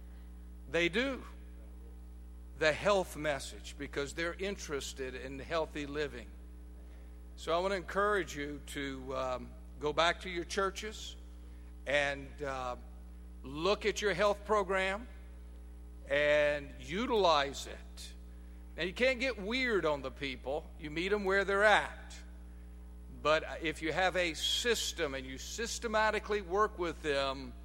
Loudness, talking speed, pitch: -34 LUFS, 130 wpm, 140 Hz